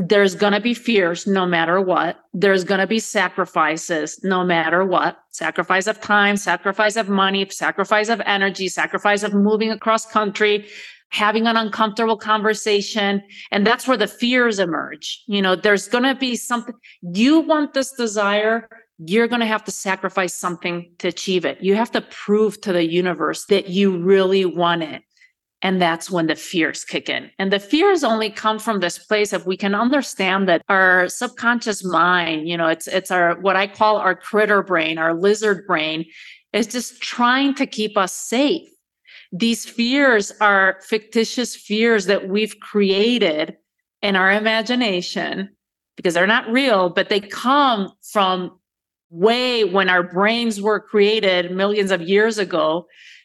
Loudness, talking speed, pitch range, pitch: -18 LUFS, 165 wpm, 185-225 Hz, 200 Hz